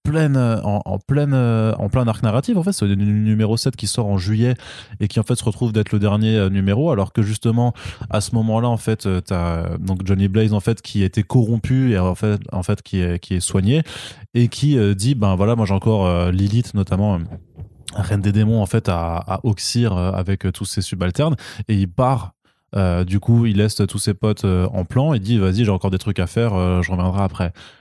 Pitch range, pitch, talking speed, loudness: 95-115 Hz, 105 Hz, 220 wpm, -19 LUFS